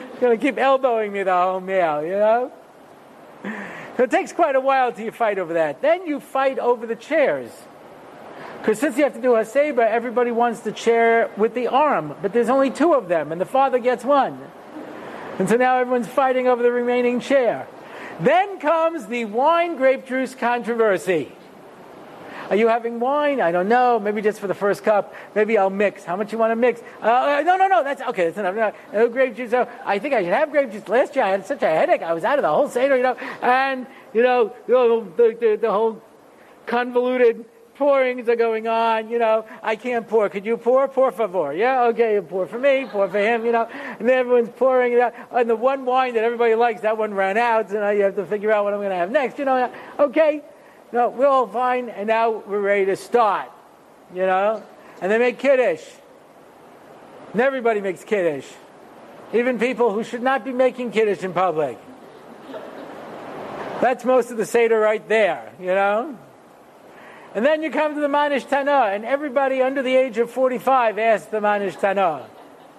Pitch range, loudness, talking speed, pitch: 215-265 Hz, -20 LUFS, 210 wpm, 240 Hz